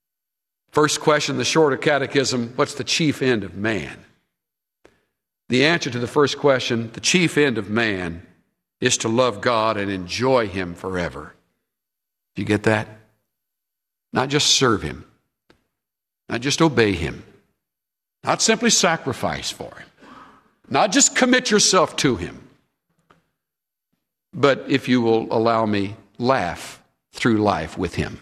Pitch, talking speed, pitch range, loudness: 120 Hz, 135 wpm, 105-145 Hz, -20 LUFS